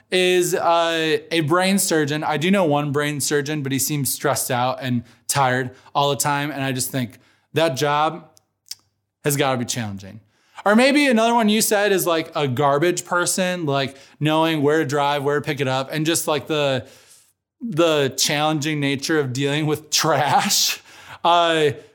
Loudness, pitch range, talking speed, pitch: -20 LUFS, 135-165 Hz, 180 wpm, 150 Hz